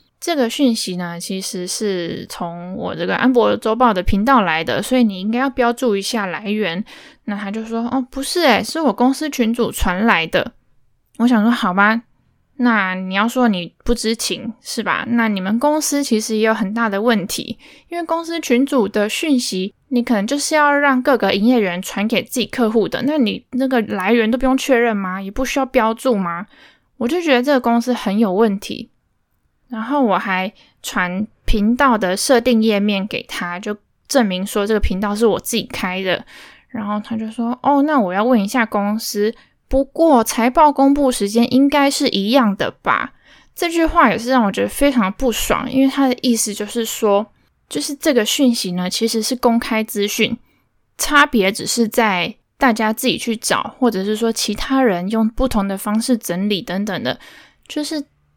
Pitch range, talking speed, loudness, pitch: 205-265 Hz, 270 characters per minute, -17 LUFS, 230 Hz